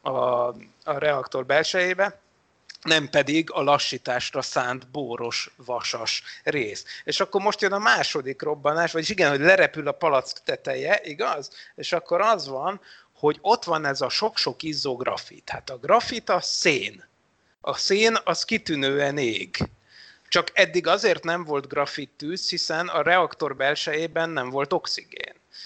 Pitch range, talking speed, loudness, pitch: 145-200 Hz, 145 wpm, -24 LUFS, 165 Hz